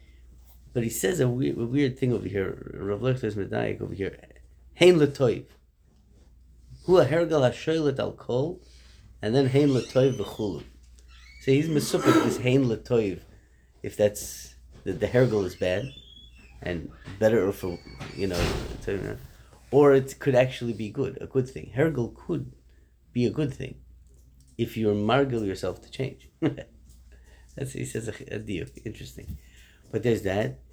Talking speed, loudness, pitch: 135 wpm, -26 LUFS, 105 Hz